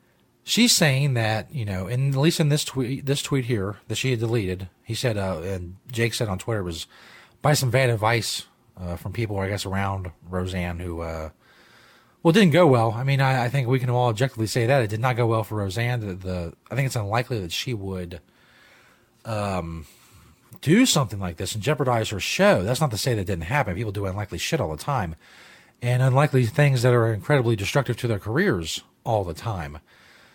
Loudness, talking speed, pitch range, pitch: -23 LUFS, 215 wpm, 95-130 Hz, 115 Hz